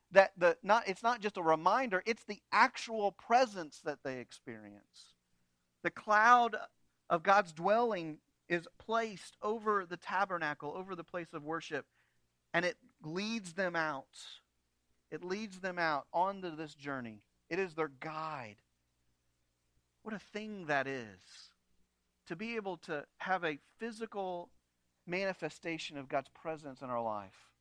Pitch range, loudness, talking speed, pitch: 115-195 Hz, -35 LUFS, 140 wpm, 165 Hz